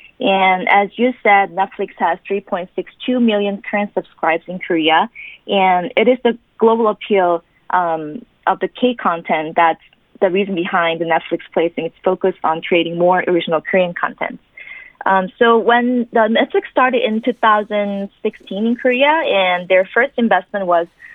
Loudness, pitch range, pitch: -16 LUFS, 175-235 Hz, 200 Hz